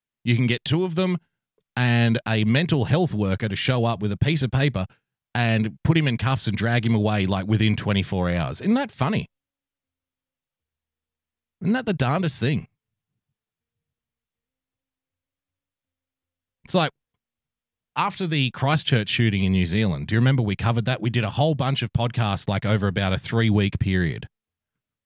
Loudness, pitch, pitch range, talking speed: -23 LUFS, 115 Hz, 95-130 Hz, 165 wpm